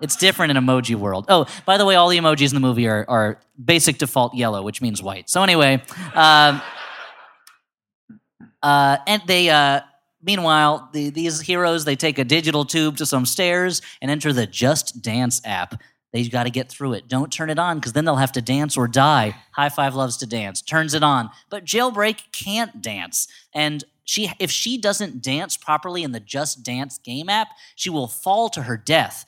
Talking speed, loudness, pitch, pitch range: 200 wpm, -19 LUFS, 145 Hz, 130-170 Hz